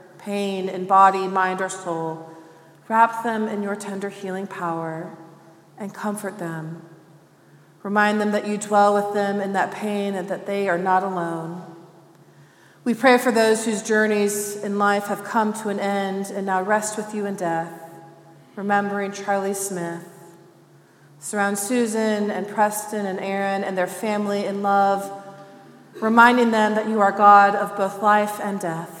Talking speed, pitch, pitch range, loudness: 160 wpm, 200 Hz, 175-210 Hz, -21 LUFS